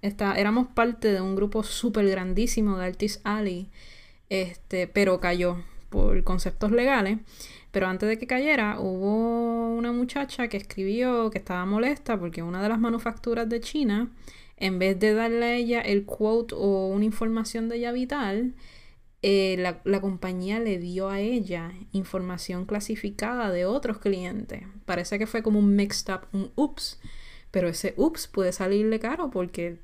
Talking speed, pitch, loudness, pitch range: 160 wpm, 205 Hz, -27 LUFS, 190-230 Hz